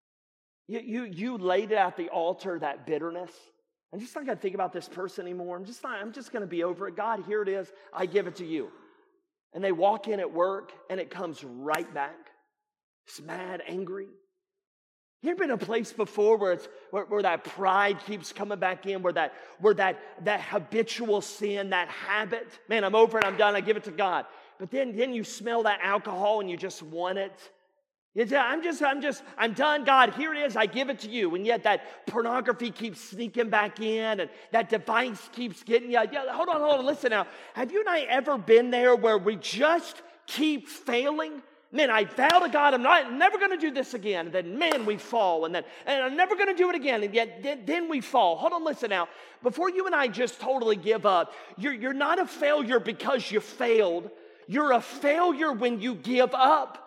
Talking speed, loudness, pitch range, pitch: 220 wpm, -27 LUFS, 195-280 Hz, 230 Hz